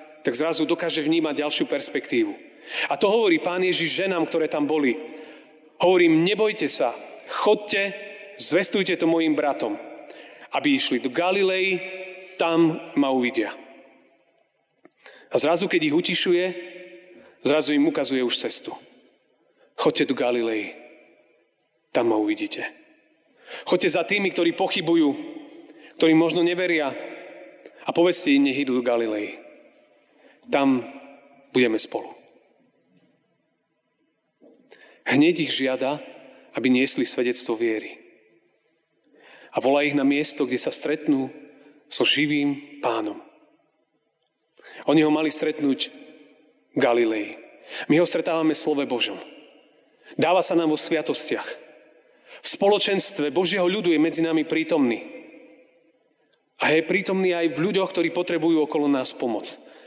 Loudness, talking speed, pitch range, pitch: -22 LUFS, 115 wpm, 145-185 Hz, 160 Hz